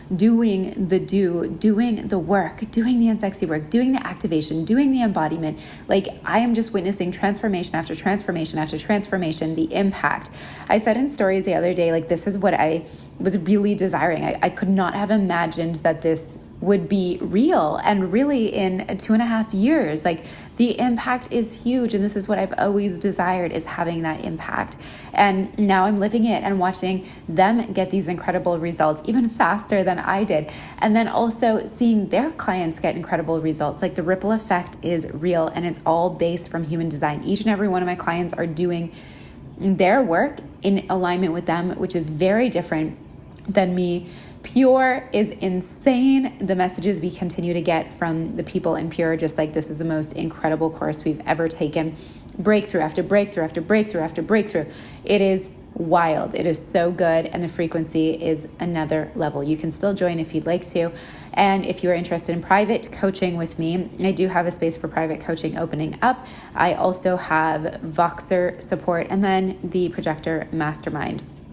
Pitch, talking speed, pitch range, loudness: 180 Hz, 185 wpm, 165-200 Hz, -22 LUFS